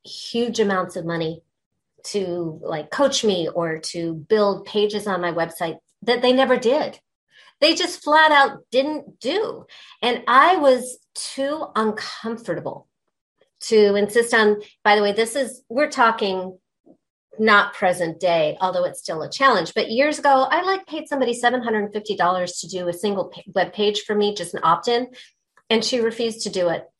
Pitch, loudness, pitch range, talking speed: 220 Hz, -20 LUFS, 185-260 Hz, 165 wpm